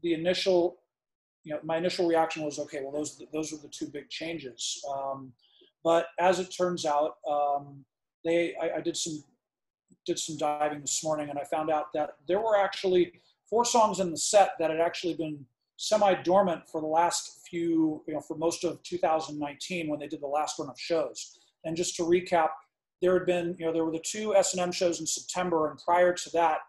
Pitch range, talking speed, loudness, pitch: 150-180 Hz, 210 wpm, -29 LUFS, 165 Hz